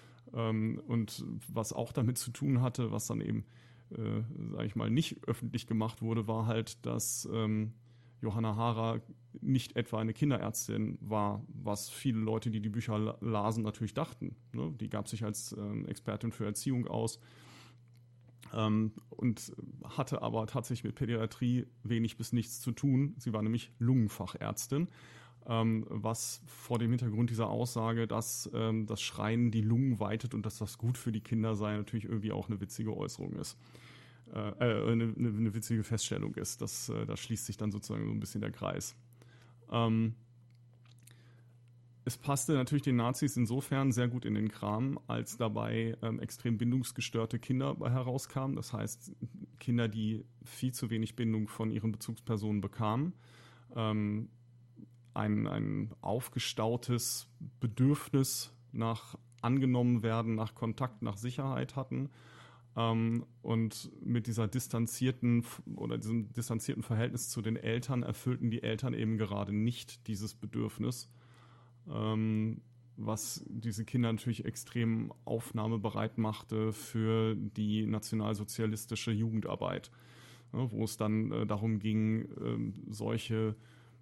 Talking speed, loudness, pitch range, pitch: 135 wpm, -35 LUFS, 110-120 Hz, 115 Hz